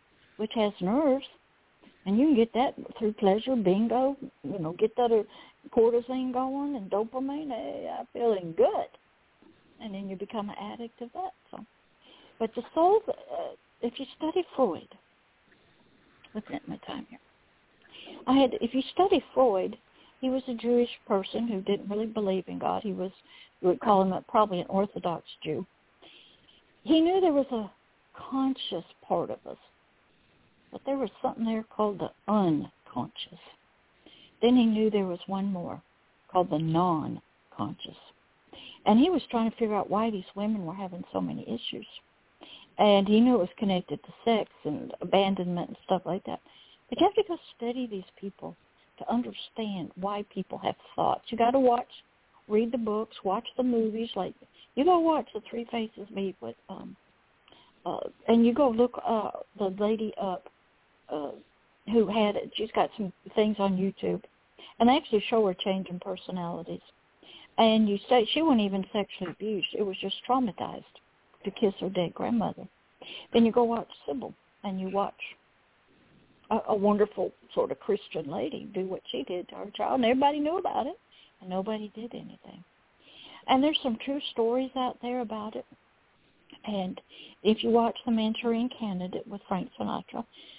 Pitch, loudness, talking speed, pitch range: 220 Hz, -29 LUFS, 170 wpm, 195-250 Hz